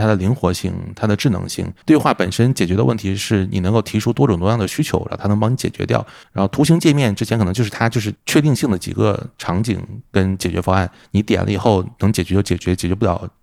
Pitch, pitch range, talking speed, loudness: 105 Hz, 95-115 Hz, 375 characters per minute, -18 LUFS